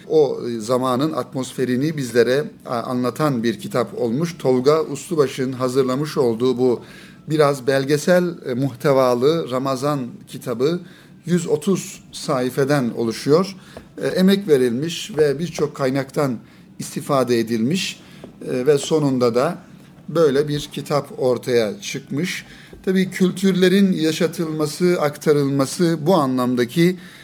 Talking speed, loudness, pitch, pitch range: 95 wpm, -20 LUFS, 150 Hz, 130-175 Hz